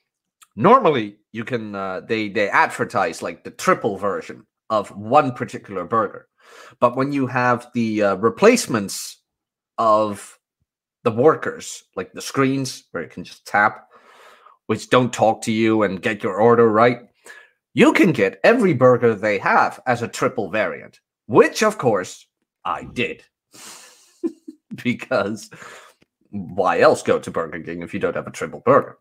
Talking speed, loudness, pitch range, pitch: 150 wpm, -19 LUFS, 110-135 Hz, 120 Hz